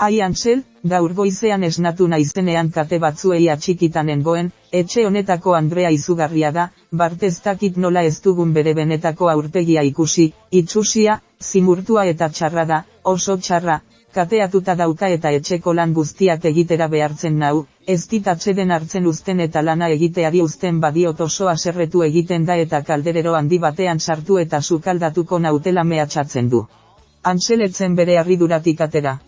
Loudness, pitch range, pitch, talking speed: -17 LUFS, 160-185 Hz, 170 Hz, 135 wpm